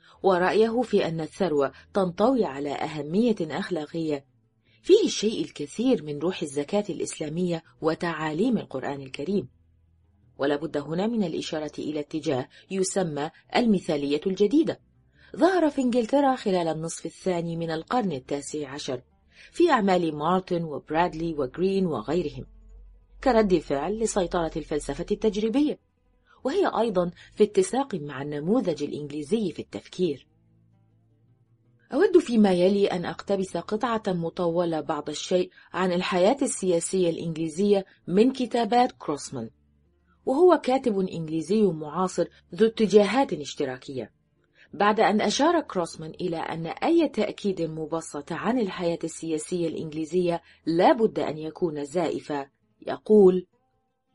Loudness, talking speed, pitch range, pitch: -26 LUFS, 110 wpm, 150-205 Hz, 175 Hz